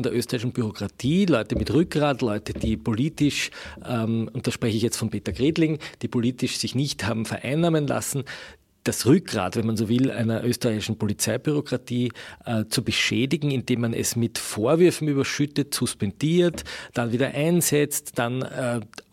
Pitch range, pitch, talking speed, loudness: 115-145 Hz, 125 Hz, 155 wpm, -24 LUFS